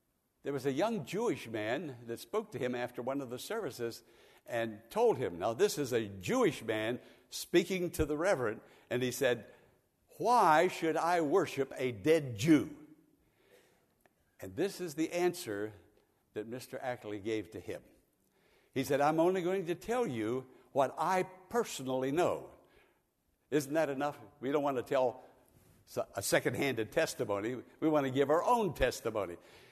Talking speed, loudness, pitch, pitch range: 160 wpm, -34 LUFS, 140 Hz, 125-170 Hz